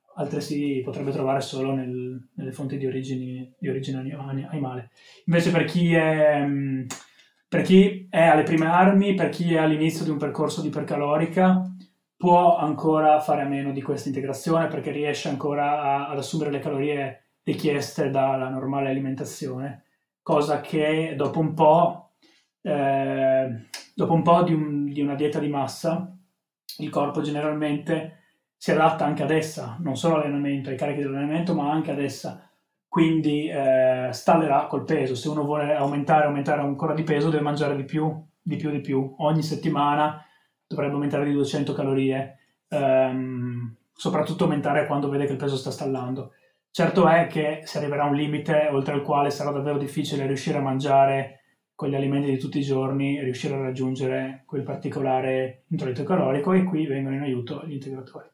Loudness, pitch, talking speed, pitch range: -24 LUFS, 145 Hz, 170 wpm, 135-155 Hz